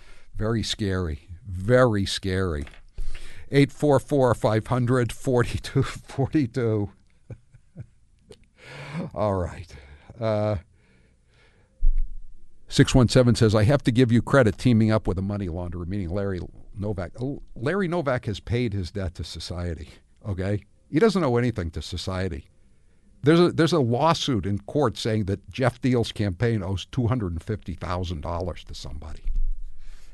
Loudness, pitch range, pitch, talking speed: -24 LUFS, 90-125 Hz, 105 Hz, 115 wpm